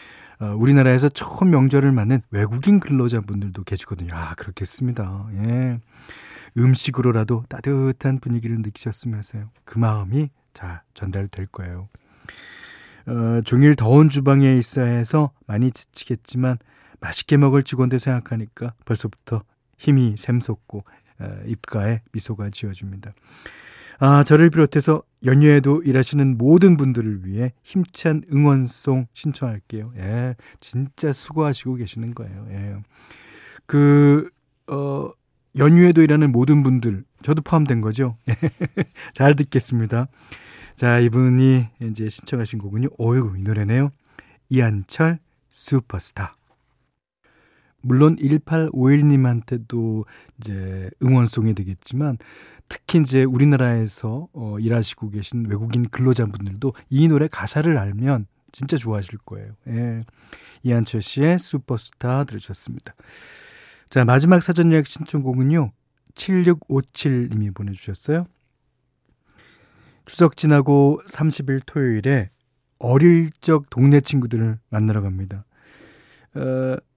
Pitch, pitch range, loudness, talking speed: 125 Hz, 110-140 Hz, -19 LUFS, 265 characters per minute